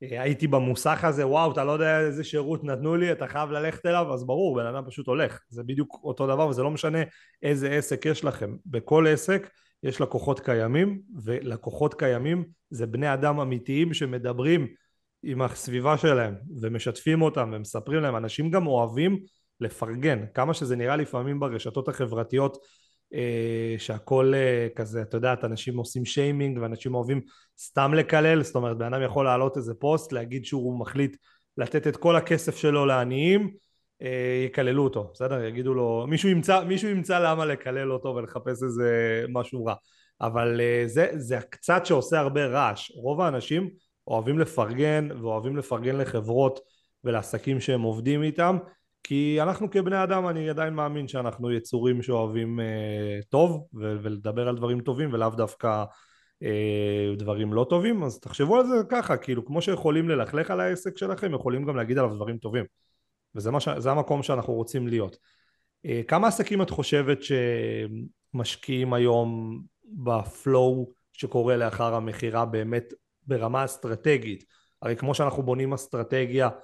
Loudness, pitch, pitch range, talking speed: -26 LUFS, 130 Hz, 120-155 Hz, 155 wpm